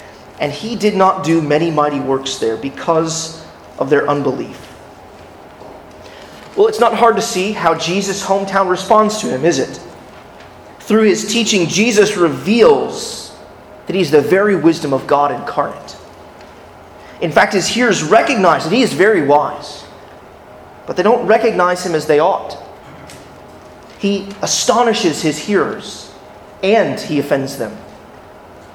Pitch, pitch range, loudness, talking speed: 185 Hz, 155-215 Hz, -14 LUFS, 140 wpm